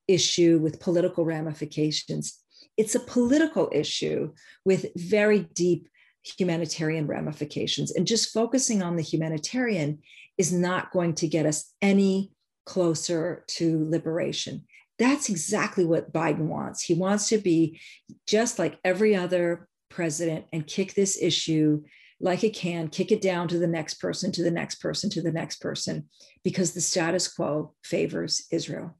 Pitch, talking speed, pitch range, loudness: 175 Hz, 145 wpm, 160-195 Hz, -26 LUFS